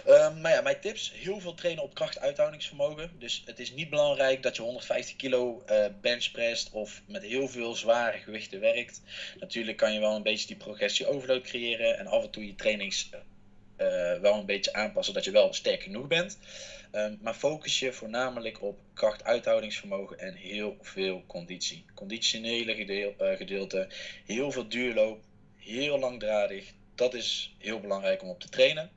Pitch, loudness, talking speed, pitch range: 120 Hz, -30 LUFS, 170 wpm, 105-170 Hz